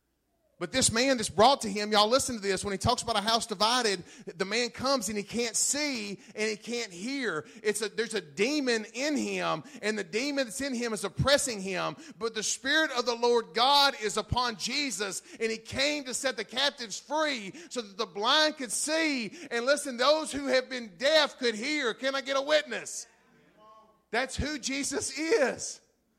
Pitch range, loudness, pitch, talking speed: 215-275 Hz, -28 LUFS, 240 Hz, 200 wpm